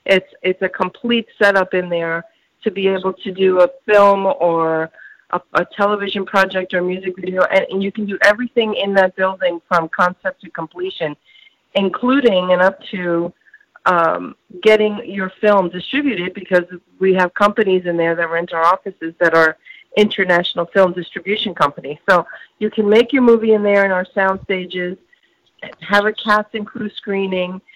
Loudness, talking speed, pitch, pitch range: -17 LUFS, 165 wpm, 190 Hz, 180-210 Hz